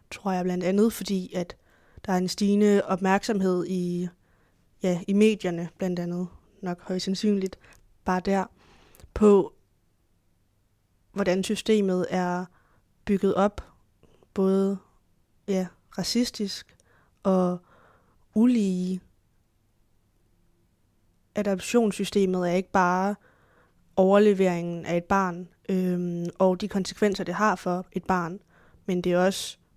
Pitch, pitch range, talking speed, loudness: 185 Hz, 175-195 Hz, 110 wpm, -26 LUFS